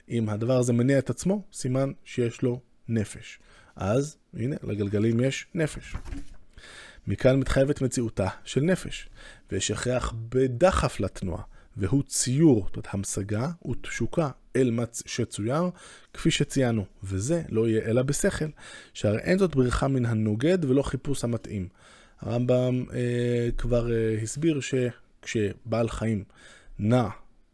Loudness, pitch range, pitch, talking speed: -27 LUFS, 110-135 Hz, 120 Hz, 125 wpm